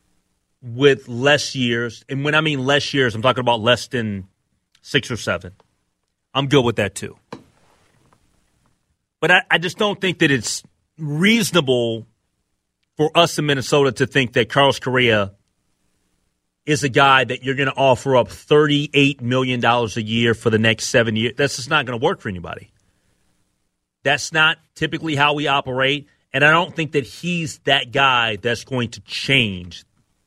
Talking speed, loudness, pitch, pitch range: 165 wpm, -18 LUFS, 130 Hz, 115-145 Hz